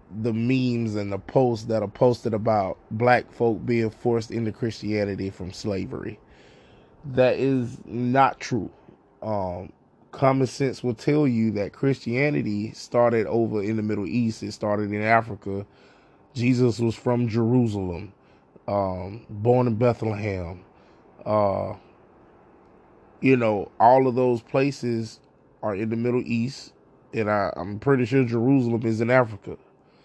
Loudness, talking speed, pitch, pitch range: -24 LUFS, 135 wpm, 115 Hz, 105-125 Hz